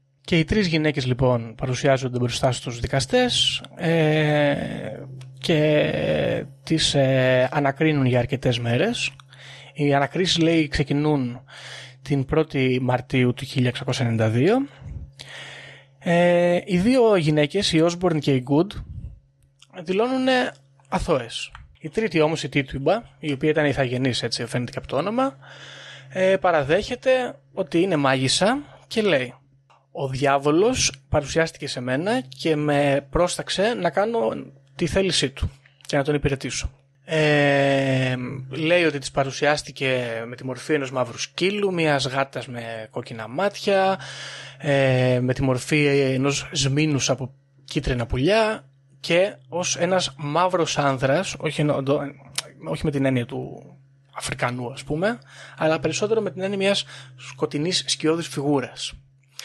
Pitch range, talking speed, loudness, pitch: 130-160 Hz, 125 wpm, -22 LUFS, 140 Hz